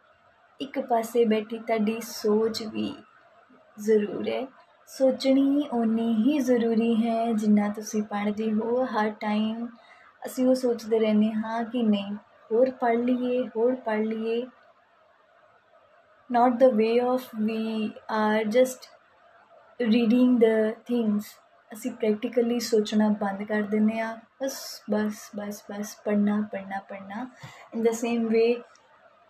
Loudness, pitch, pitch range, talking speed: -26 LUFS, 230 Hz, 215-250 Hz, 125 wpm